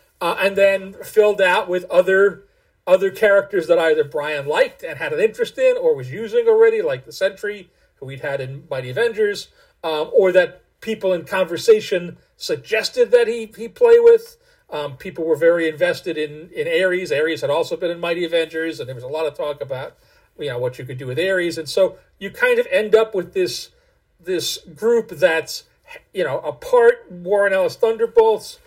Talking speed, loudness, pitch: 195 wpm, -19 LUFS, 200 Hz